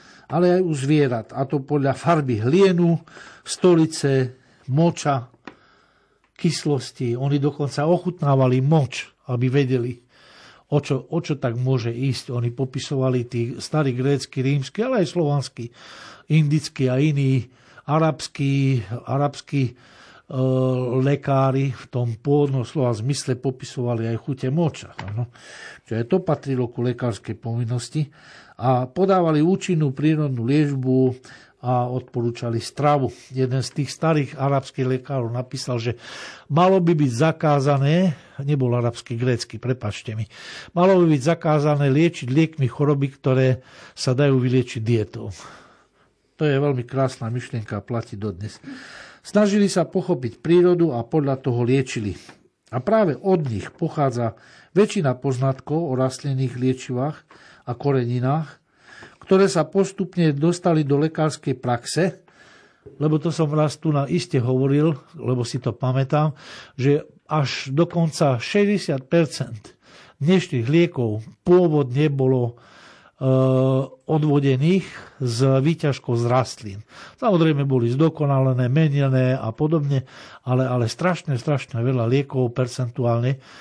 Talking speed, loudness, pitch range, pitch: 120 wpm, -21 LUFS, 125-155 Hz, 135 Hz